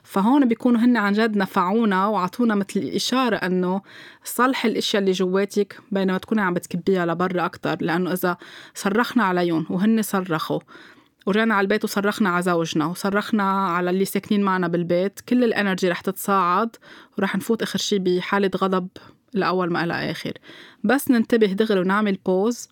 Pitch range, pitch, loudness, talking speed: 185-220 Hz, 195 Hz, -21 LUFS, 150 wpm